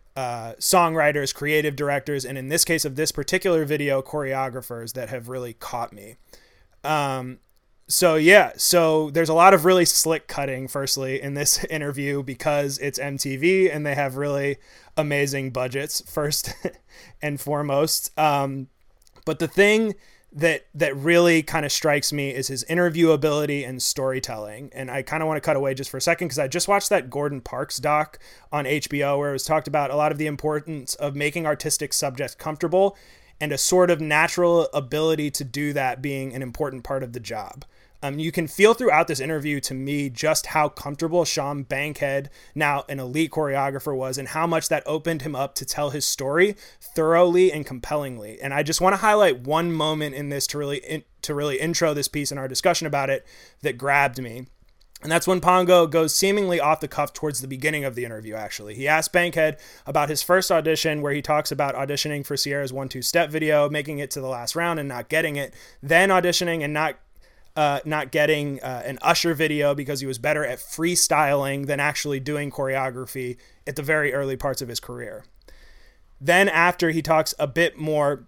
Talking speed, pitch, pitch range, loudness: 195 wpm, 150 Hz, 140-160 Hz, -22 LUFS